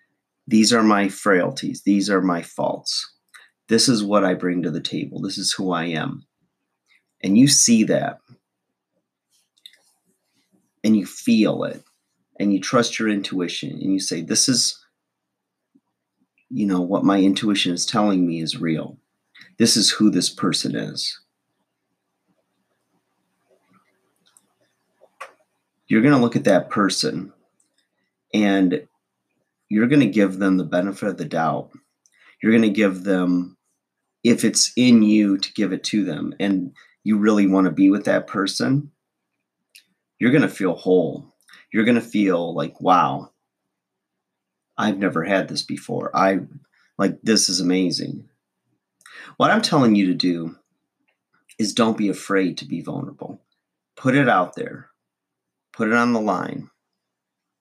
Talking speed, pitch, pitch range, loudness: 145 wpm, 95 Hz, 90-105 Hz, -20 LUFS